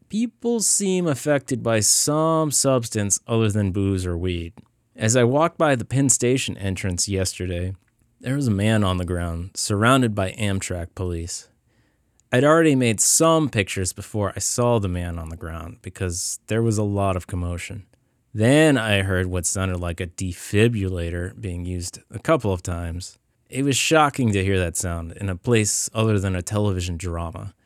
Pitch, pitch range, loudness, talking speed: 100 Hz, 90-125 Hz, -21 LUFS, 175 wpm